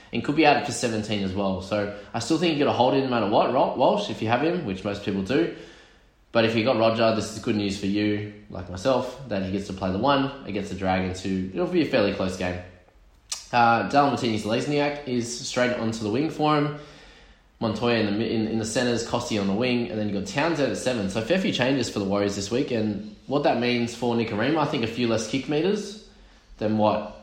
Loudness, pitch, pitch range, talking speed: -24 LUFS, 115 Hz, 100-125 Hz, 255 wpm